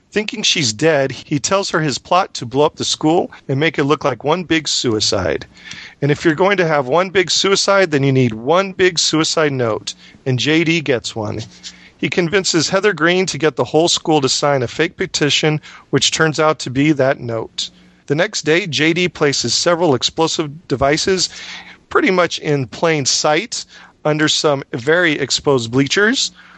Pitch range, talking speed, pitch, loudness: 140-170 Hz, 180 wpm, 155 Hz, -16 LUFS